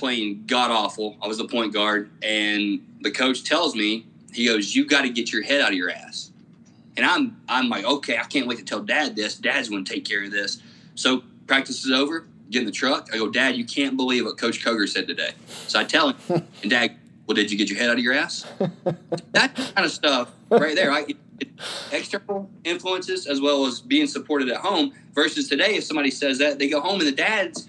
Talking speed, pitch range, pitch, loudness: 230 wpm, 120-185 Hz, 140 Hz, -22 LUFS